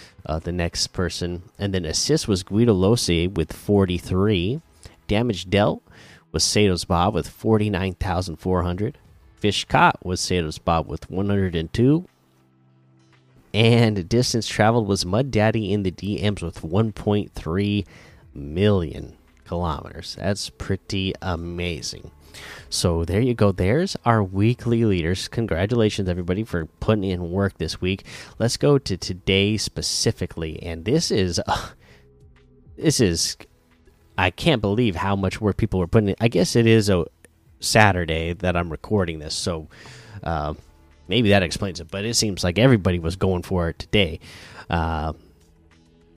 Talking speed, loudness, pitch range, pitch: 140 wpm, -22 LUFS, 85-105 Hz, 95 Hz